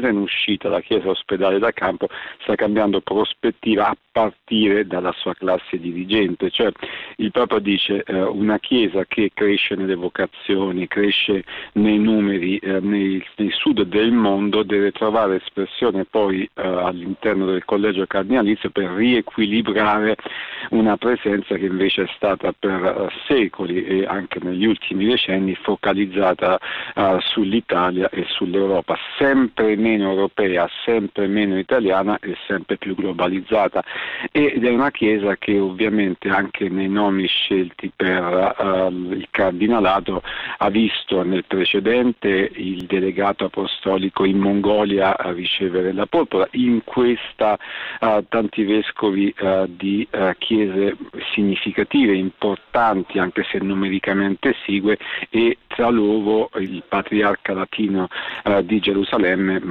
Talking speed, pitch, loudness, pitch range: 125 wpm, 100 Hz, -19 LUFS, 95-105 Hz